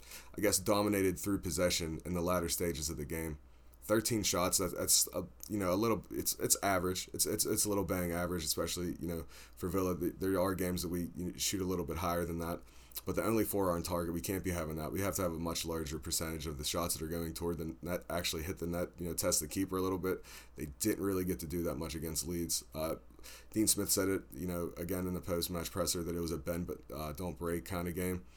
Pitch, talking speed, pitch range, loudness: 85 Hz, 255 wpm, 80-95 Hz, -35 LUFS